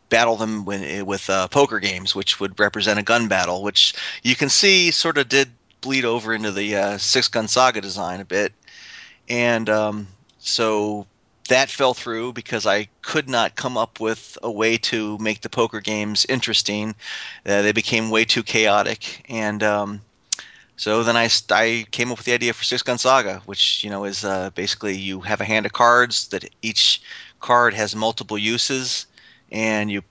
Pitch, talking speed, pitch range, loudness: 110 Hz, 185 wpm, 105-120 Hz, -20 LUFS